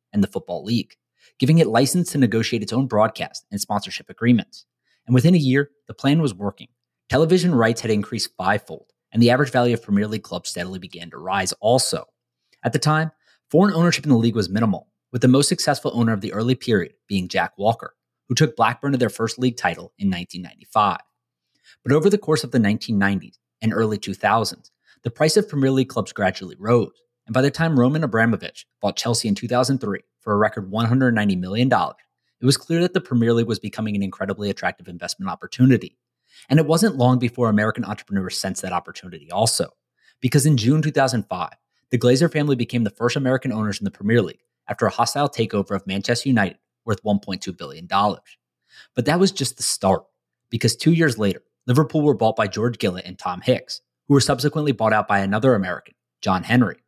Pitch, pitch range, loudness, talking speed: 120 Hz, 105-140 Hz, -21 LUFS, 195 wpm